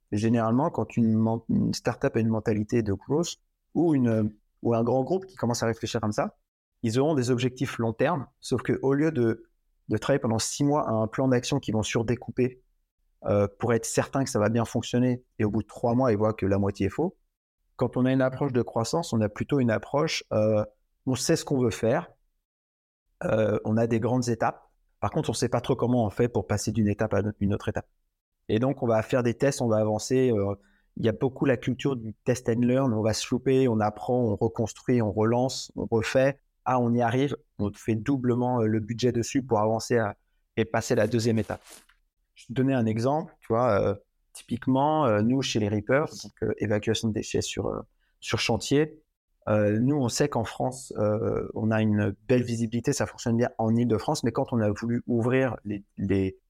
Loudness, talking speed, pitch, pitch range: -26 LUFS, 220 wpm, 115 Hz, 110-130 Hz